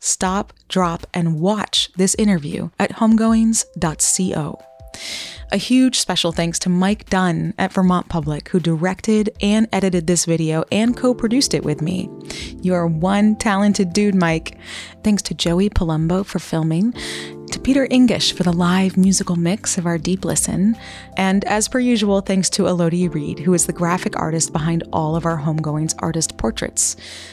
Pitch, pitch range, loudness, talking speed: 185 Hz, 170-205 Hz, -18 LUFS, 160 wpm